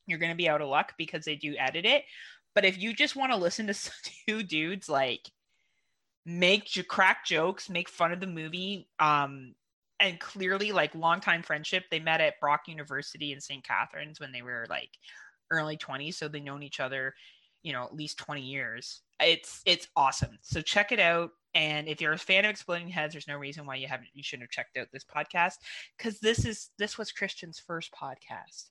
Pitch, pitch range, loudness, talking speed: 160 Hz, 145-185 Hz, -29 LUFS, 205 wpm